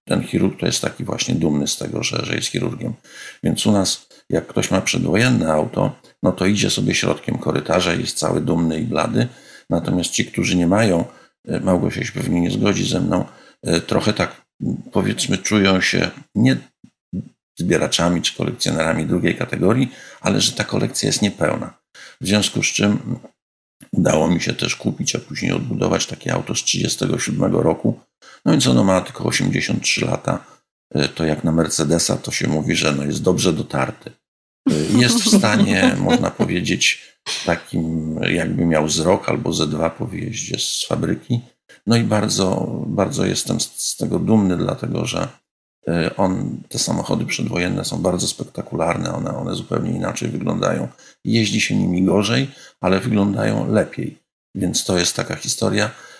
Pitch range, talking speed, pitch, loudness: 80-105 Hz, 160 wpm, 90 Hz, -19 LUFS